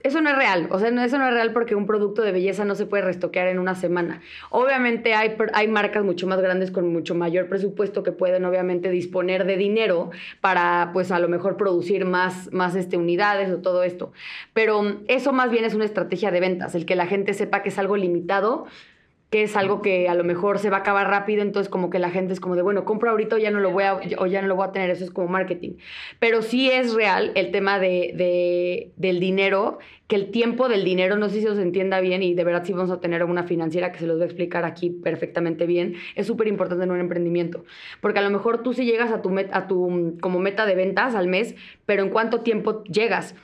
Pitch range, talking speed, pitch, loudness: 180-210 Hz, 240 wpm, 190 Hz, -22 LUFS